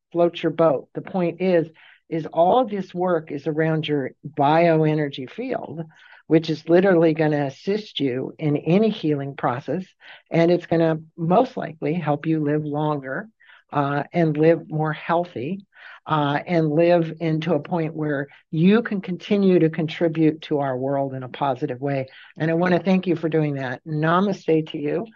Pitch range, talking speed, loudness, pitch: 150-175 Hz, 175 wpm, -22 LUFS, 160 Hz